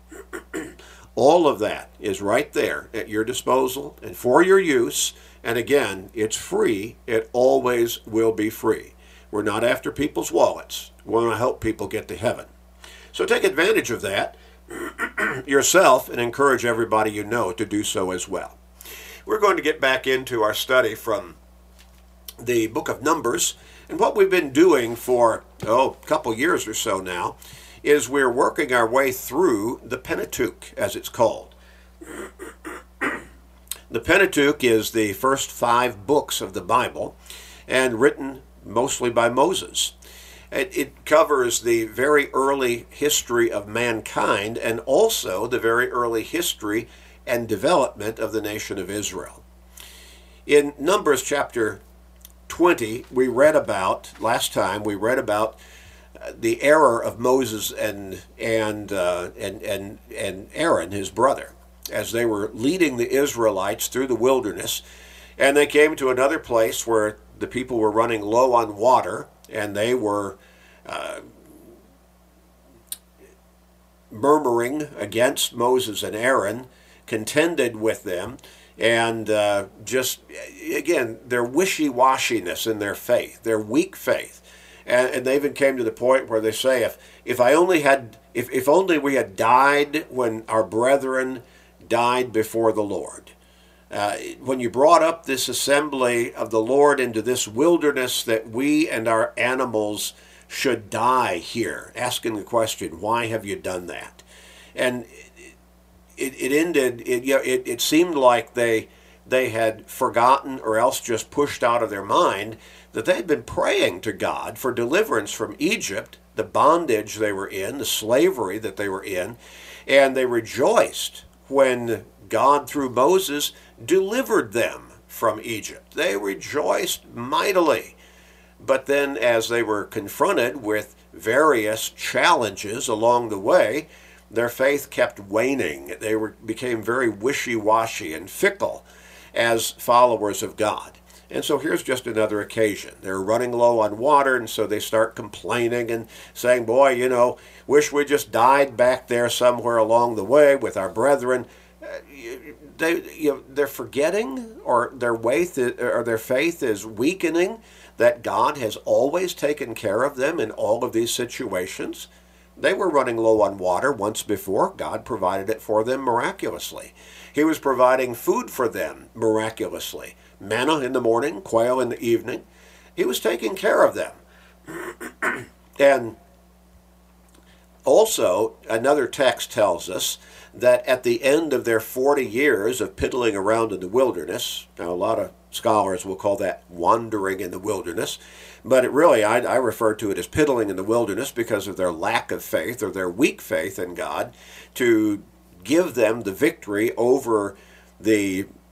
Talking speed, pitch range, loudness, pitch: 150 wpm, 105-140 Hz, -21 LUFS, 120 Hz